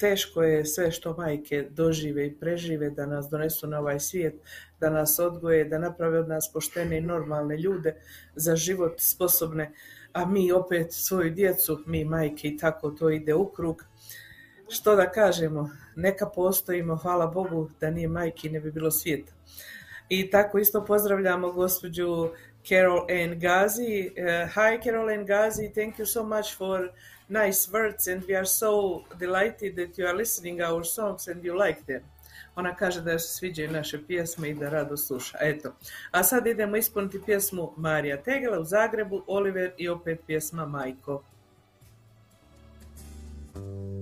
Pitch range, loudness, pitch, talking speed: 155-190 Hz, -27 LUFS, 170 Hz, 160 wpm